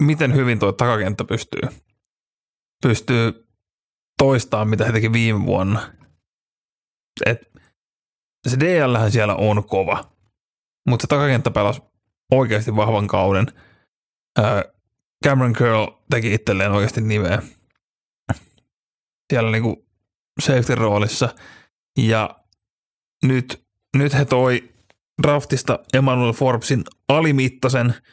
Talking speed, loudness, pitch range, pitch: 95 wpm, -19 LUFS, 105-130 Hz, 115 Hz